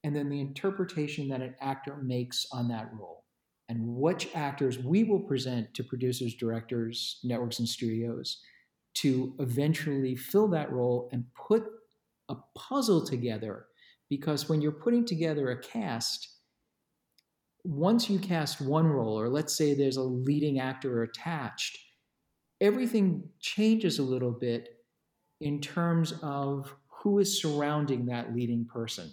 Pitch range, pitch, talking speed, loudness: 125-165 Hz, 140 Hz, 140 wpm, -31 LUFS